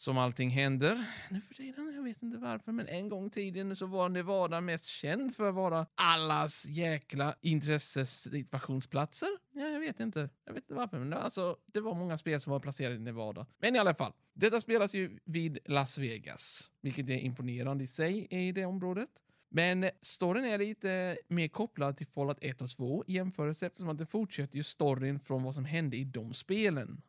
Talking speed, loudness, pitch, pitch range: 200 wpm, -35 LUFS, 165 Hz, 140-195 Hz